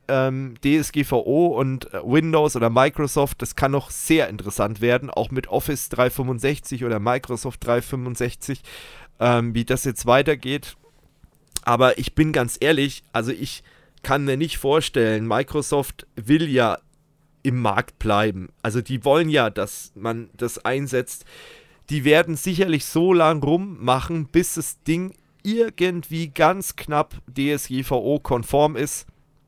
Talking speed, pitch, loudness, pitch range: 125 wpm, 135 Hz, -22 LUFS, 125-155 Hz